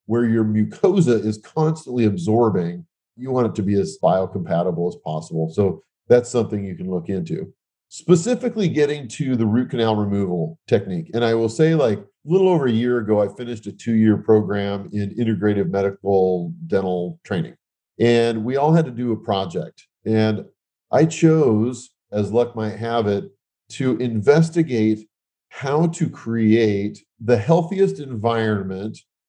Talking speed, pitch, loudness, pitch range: 155 wpm, 115 Hz, -20 LUFS, 100-130 Hz